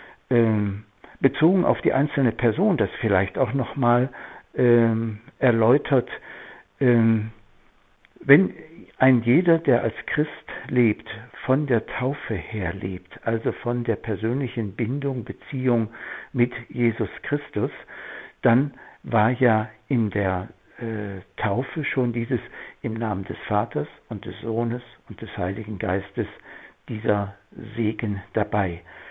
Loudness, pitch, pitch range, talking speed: -24 LUFS, 115 Hz, 105-125 Hz, 120 wpm